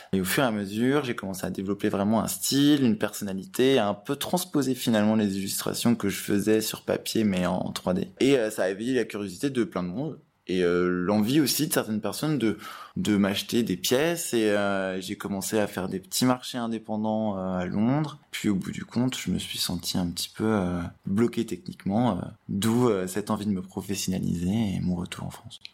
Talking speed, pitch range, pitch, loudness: 220 wpm, 95-120 Hz, 105 Hz, -26 LUFS